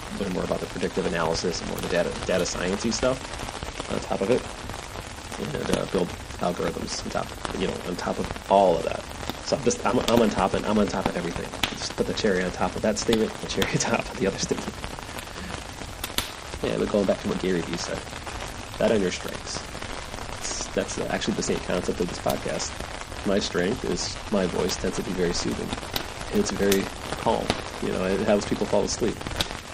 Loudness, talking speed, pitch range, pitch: -27 LUFS, 210 wpm, 95-110 Hz, 100 Hz